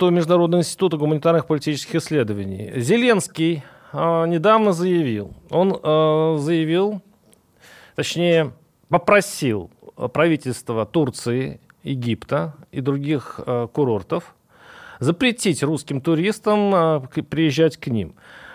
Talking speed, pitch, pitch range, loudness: 90 wpm, 160 Hz, 140-175 Hz, -20 LUFS